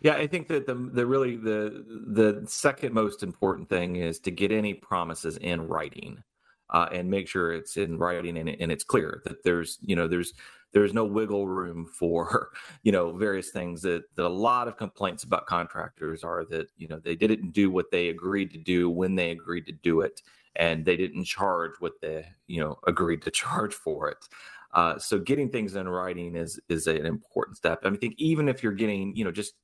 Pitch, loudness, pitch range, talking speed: 95 Hz, -28 LUFS, 85-110 Hz, 215 wpm